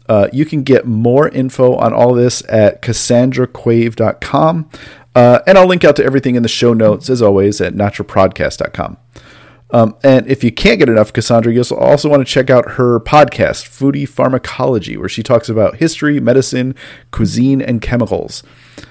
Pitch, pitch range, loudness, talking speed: 120 Hz, 115-135 Hz, -11 LUFS, 165 wpm